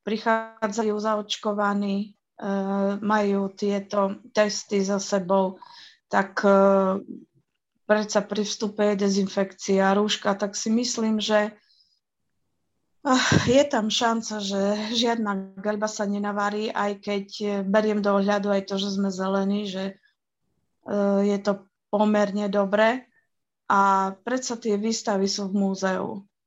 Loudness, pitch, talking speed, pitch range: -24 LUFS, 205 Hz, 110 wpm, 200-215 Hz